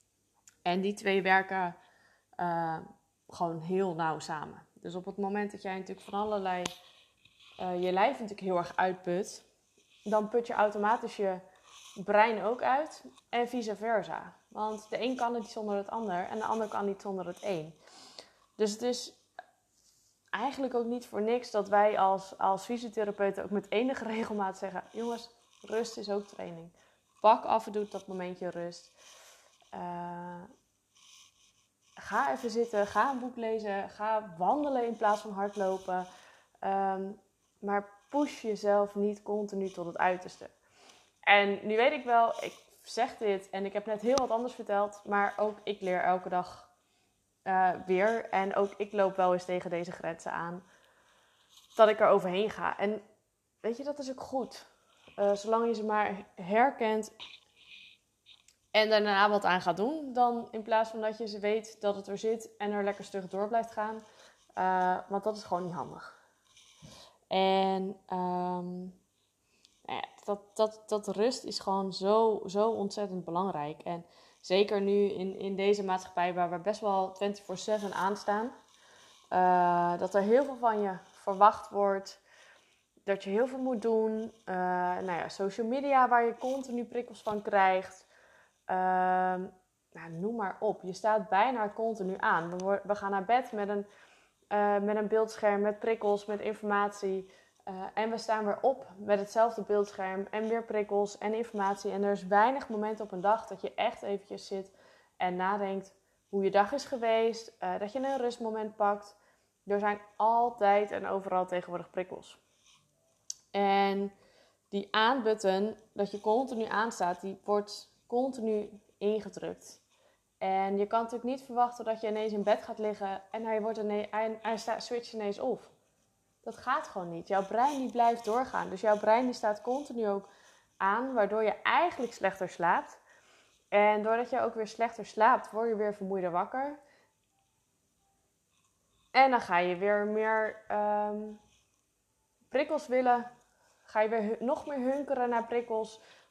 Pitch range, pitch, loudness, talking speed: 195-225 Hz, 205 Hz, -31 LUFS, 165 wpm